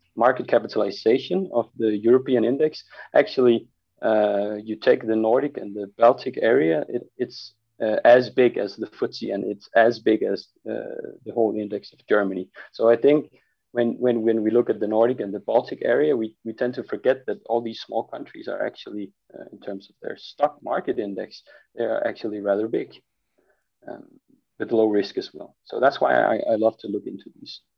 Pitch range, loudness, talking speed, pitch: 105-120 Hz, -23 LUFS, 195 wpm, 115 Hz